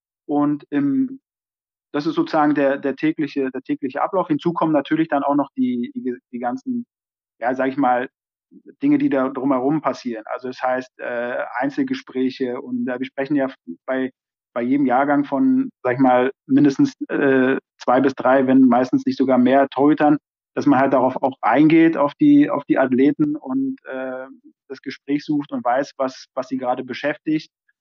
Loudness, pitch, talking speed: -20 LUFS, 140 Hz, 180 wpm